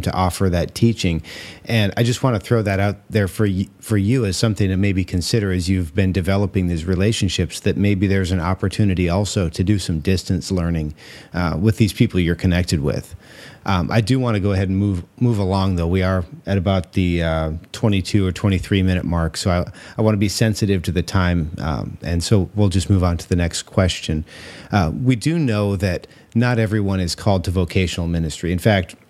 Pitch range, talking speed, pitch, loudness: 90-105 Hz, 215 wpm, 95 Hz, -20 LUFS